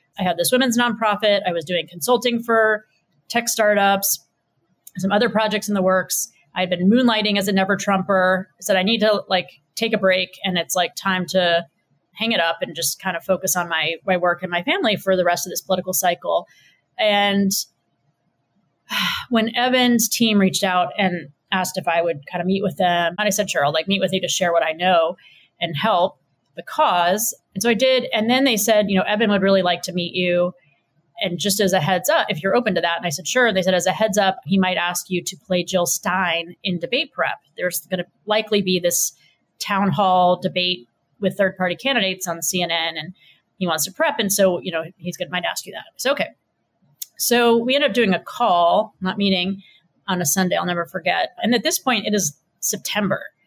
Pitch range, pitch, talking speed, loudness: 175-210 Hz, 185 Hz, 225 wpm, -20 LUFS